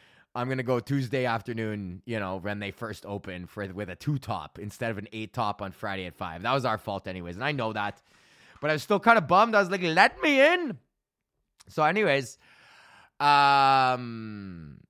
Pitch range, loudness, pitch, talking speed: 100-140 Hz, -26 LUFS, 115 Hz, 205 wpm